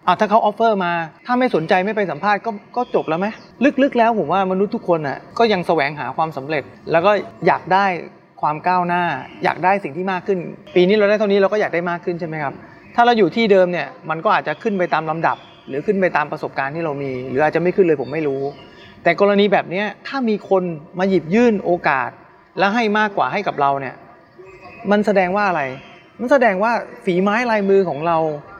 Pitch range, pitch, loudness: 170-210 Hz, 190 Hz, -18 LUFS